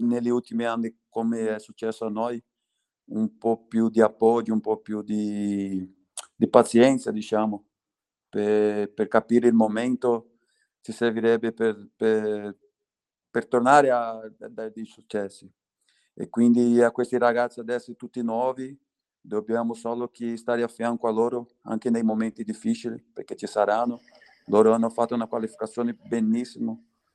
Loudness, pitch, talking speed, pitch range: -25 LUFS, 115 Hz, 145 wpm, 110-120 Hz